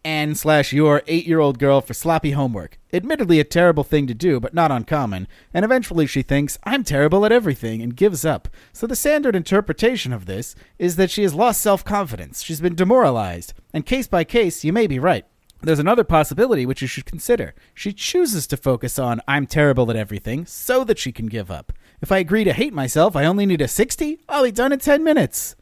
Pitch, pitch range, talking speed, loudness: 155 Hz, 135-205 Hz, 210 wpm, -19 LUFS